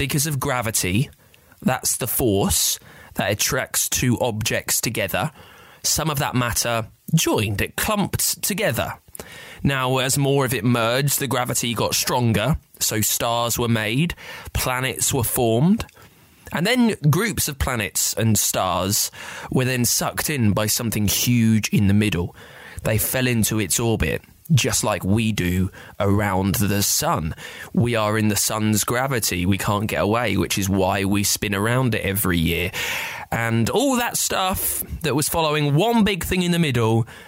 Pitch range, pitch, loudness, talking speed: 105-130 Hz, 115 Hz, -20 LUFS, 155 wpm